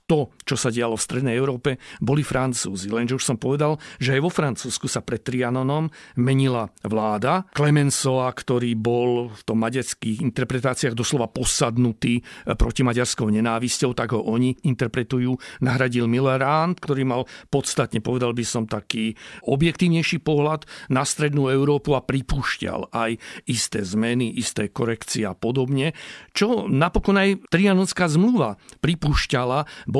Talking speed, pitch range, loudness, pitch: 135 wpm, 120-145 Hz, -22 LUFS, 130 Hz